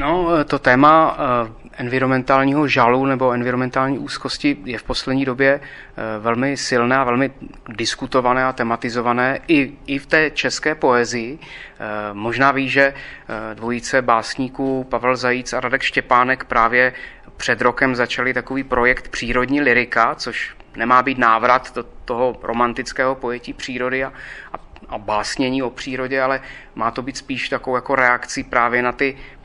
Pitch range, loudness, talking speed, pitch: 120-135 Hz, -18 LUFS, 140 wpm, 130 Hz